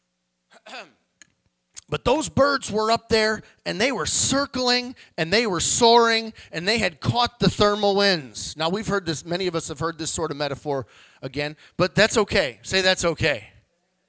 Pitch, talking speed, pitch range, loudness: 185 Hz, 175 wpm, 160-220 Hz, -21 LUFS